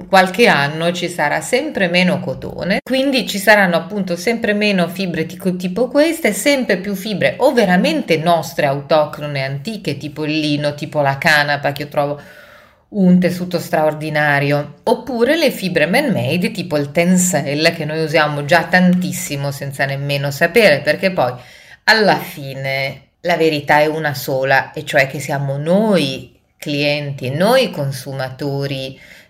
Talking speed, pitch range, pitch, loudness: 145 wpm, 145-190 Hz, 160 Hz, -16 LUFS